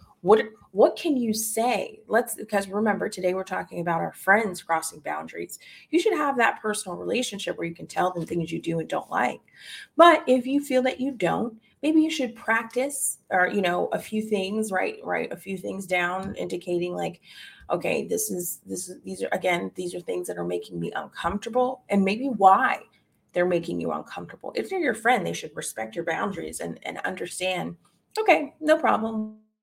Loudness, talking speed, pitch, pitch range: -25 LUFS, 195 wpm, 205 Hz, 180-255 Hz